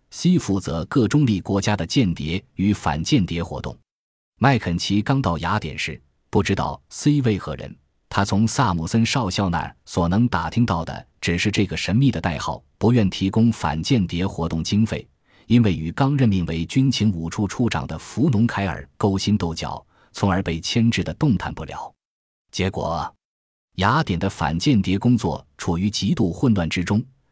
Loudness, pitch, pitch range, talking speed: -21 LUFS, 100 Hz, 85-115 Hz, 255 characters per minute